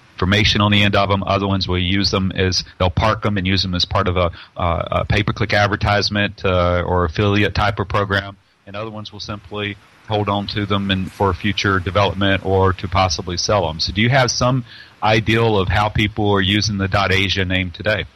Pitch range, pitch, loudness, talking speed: 95-105 Hz, 100 Hz, -17 LUFS, 215 wpm